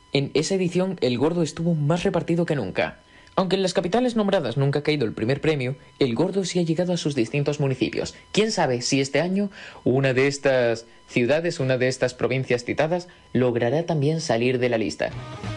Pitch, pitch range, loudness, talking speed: 145 Hz, 125-175 Hz, -23 LUFS, 195 wpm